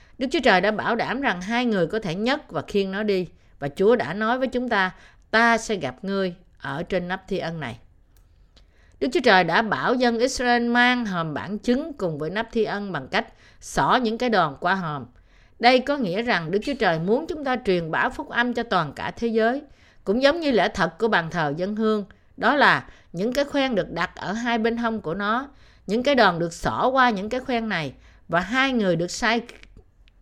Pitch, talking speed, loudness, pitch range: 215 Hz, 225 wpm, -23 LUFS, 175-240 Hz